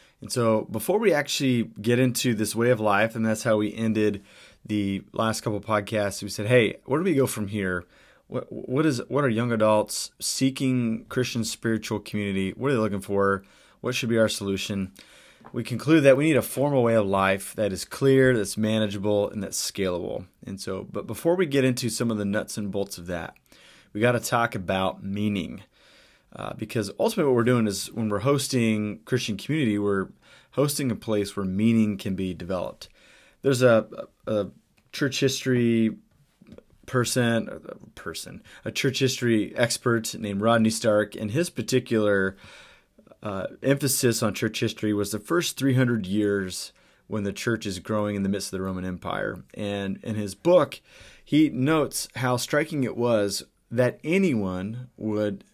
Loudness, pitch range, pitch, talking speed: -25 LUFS, 100-125 Hz, 110 Hz, 175 wpm